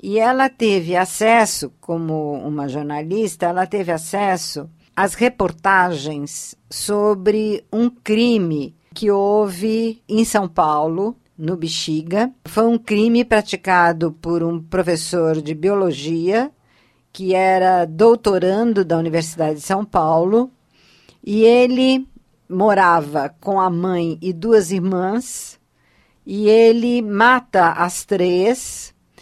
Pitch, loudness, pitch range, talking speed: 190 Hz, -17 LUFS, 165-220 Hz, 110 wpm